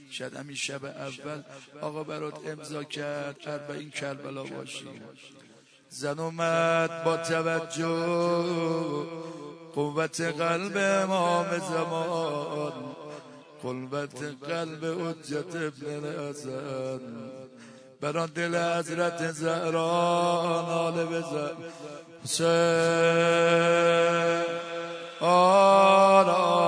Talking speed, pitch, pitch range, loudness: 80 wpm, 165 Hz, 145-170 Hz, -27 LUFS